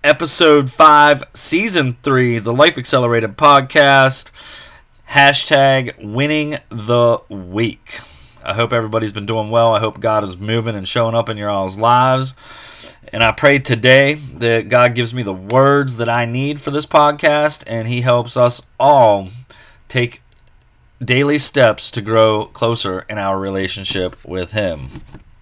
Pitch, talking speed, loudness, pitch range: 120 Hz, 145 wpm, -14 LUFS, 110-140 Hz